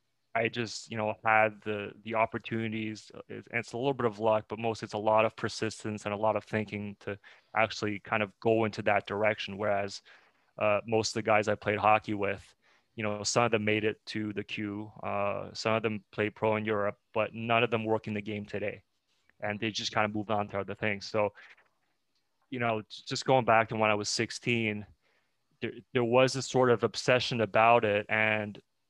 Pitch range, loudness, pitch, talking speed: 105-115 Hz, -30 LUFS, 110 Hz, 215 wpm